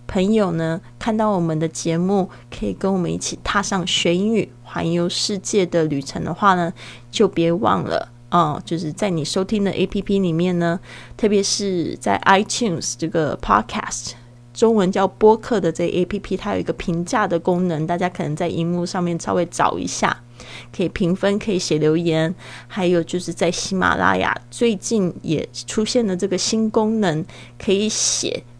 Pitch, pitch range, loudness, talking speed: 175 Hz, 160-195 Hz, -20 LUFS, 285 characters per minute